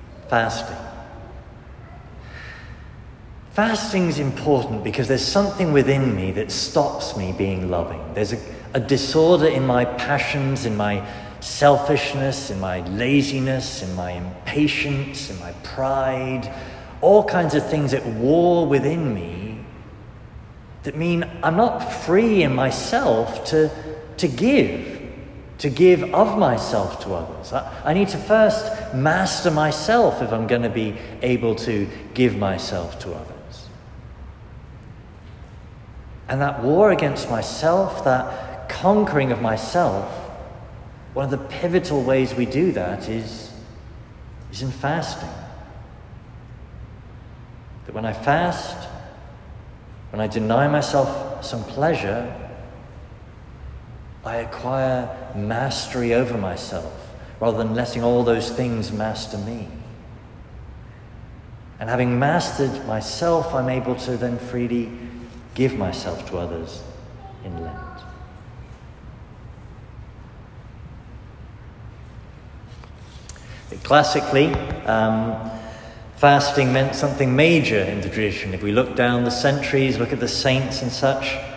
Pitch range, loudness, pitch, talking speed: 110-140 Hz, -21 LUFS, 125 Hz, 115 wpm